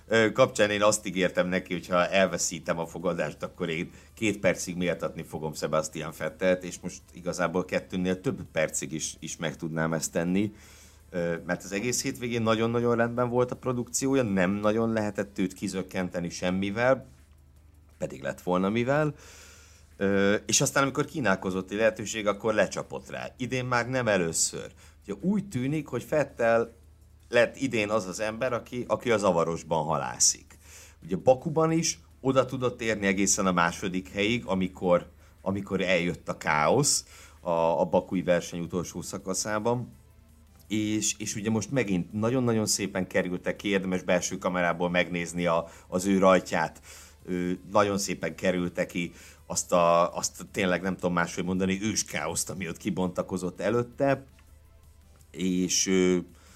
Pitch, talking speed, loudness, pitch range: 95 Hz, 145 wpm, -28 LUFS, 85-110 Hz